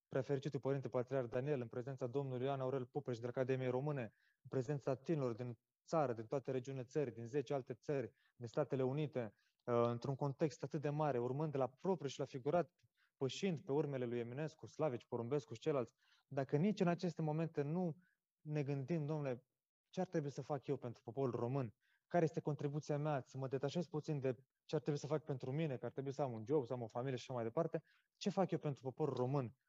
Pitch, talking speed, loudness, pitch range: 140 Hz, 210 wpm, -42 LUFS, 130-155 Hz